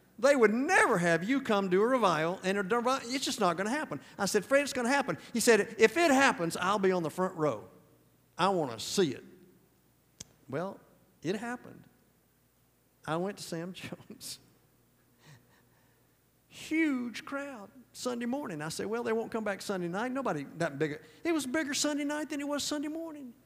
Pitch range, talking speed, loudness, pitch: 185-280 Hz, 190 wpm, -30 LUFS, 230 Hz